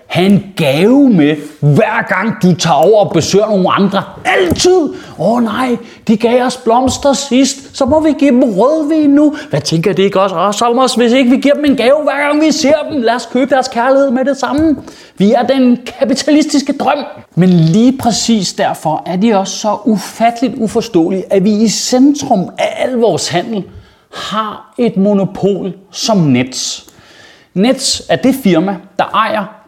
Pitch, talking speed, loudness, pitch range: 230 Hz, 180 wpm, -11 LUFS, 195-265 Hz